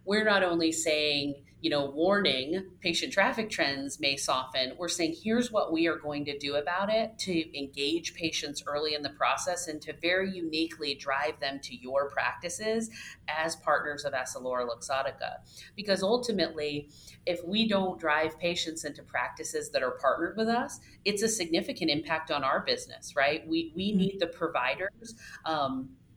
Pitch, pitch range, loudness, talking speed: 165 Hz, 145-190 Hz, -30 LUFS, 165 wpm